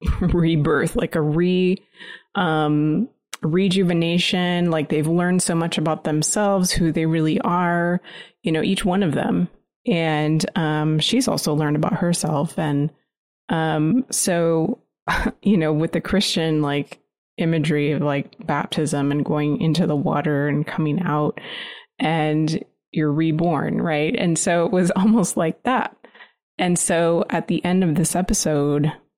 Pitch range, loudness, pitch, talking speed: 155-185 Hz, -21 LUFS, 165 Hz, 145 wpm